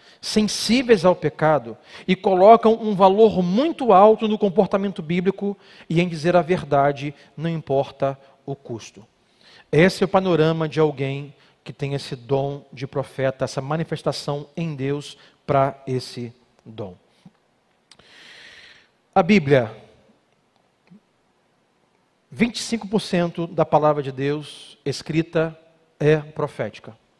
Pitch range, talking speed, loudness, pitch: 140-195 Hz, 110 wpm, -20 LUFS, 155 Hz